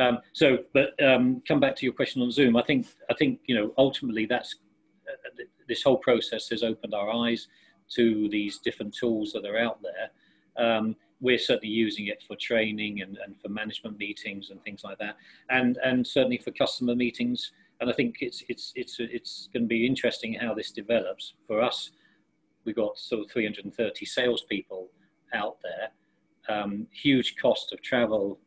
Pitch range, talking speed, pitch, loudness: 105-130 Hz, 185 wpm, 120 Hz, -27 LUFS